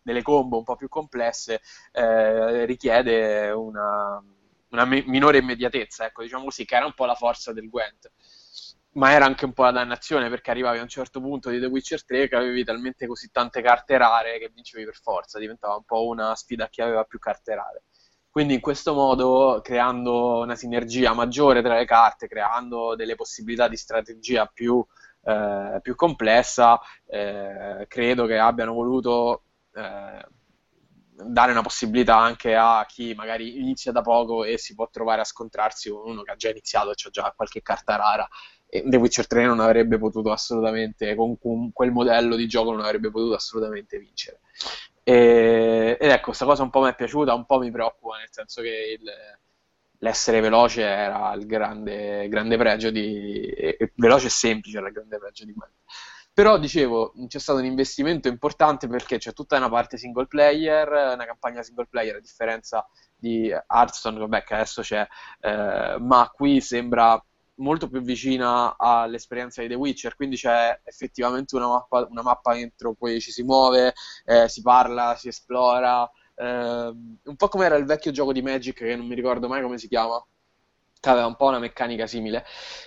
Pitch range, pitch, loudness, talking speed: 115-130 Hz, 120 Hz, -22 LUFS, 180 wpm